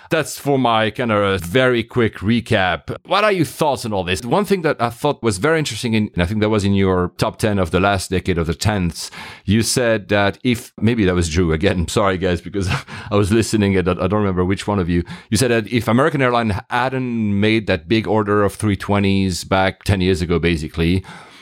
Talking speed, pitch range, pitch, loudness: 230 wpm, 95-115 Hz, 105 Hz, -18 LUFS